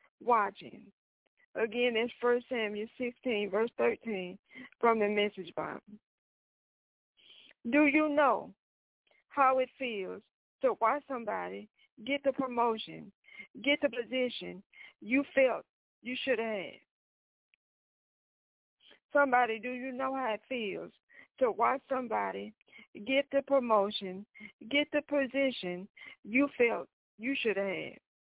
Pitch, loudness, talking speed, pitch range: 245 Hz, -32 LUFS, 110 wpm, 210-275 Hz